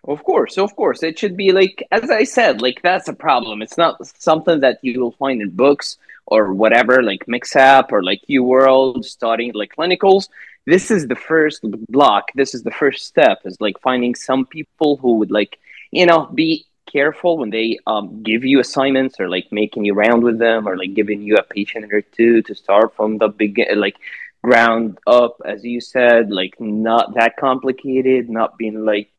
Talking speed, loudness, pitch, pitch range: 200 wpm, -16 LUFS, 125 Hz, 110-140 Hz